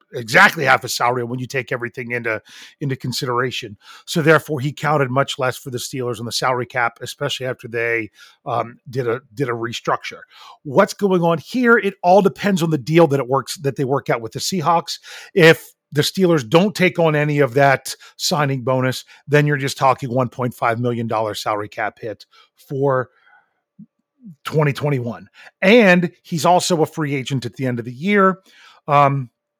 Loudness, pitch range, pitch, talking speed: -18 LUFS, 125-165 Hz, 140 Hz, 180 wpm